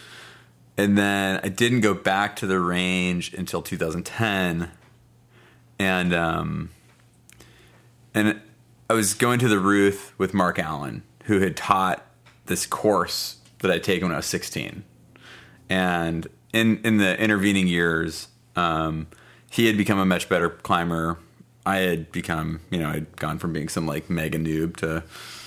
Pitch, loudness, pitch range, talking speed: 95 Hz, -23 LUFS, 85-110 Hz, 150 wpm